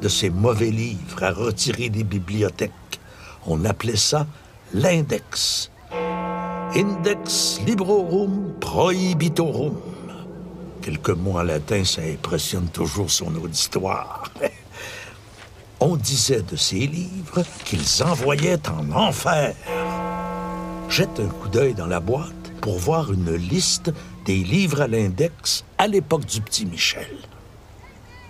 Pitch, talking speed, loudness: 130 Hz, 110 wpm, -22 LUFS